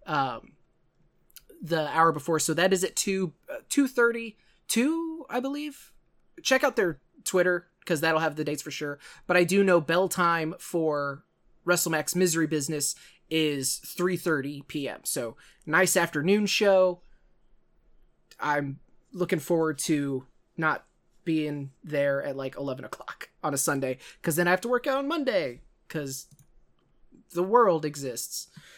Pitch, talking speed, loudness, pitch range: 170 Hz, 150 wpm, -27 LUFS, 150-190 Hz